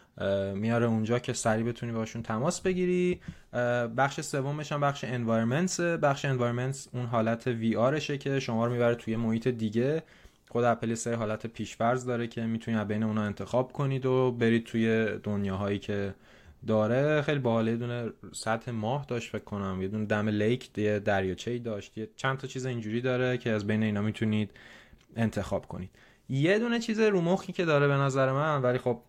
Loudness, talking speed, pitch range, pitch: -29 LUFS, 175 wpm, 110-135 Hz, 120 Hz